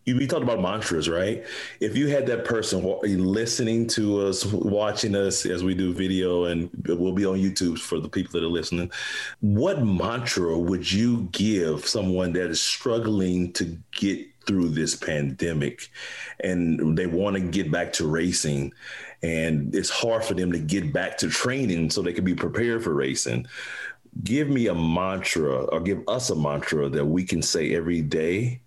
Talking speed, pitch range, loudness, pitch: 175 wpm, 85-105 Hz, -25 LUFS, 90 Hz